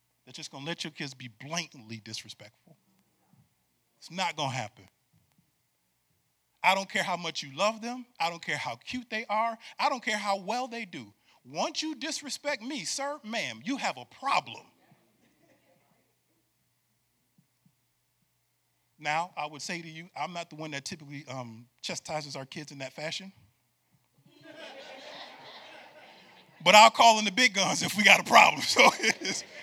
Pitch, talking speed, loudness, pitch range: 170 Hz, 160 wpm, -27 LUFS, 135-220 Hz